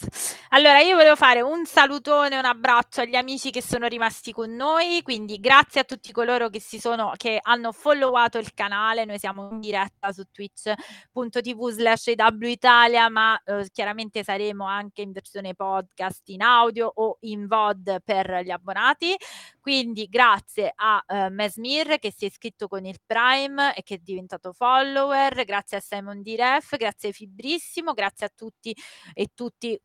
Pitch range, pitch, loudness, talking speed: 205-255 Hz, 225 Hz, -21 LUFS, 160 wpm